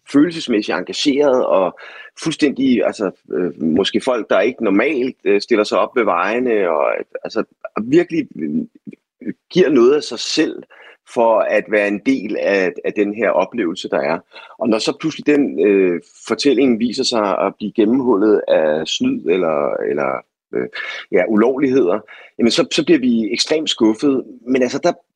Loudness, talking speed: -17 LUFS, 150 wpm